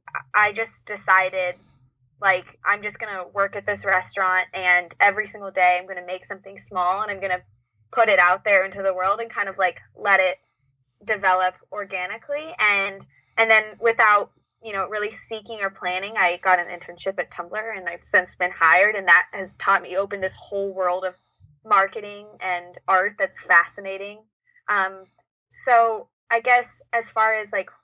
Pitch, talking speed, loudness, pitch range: 195 Hz, 180 wpm, -21 LUFS, 180-210 Hz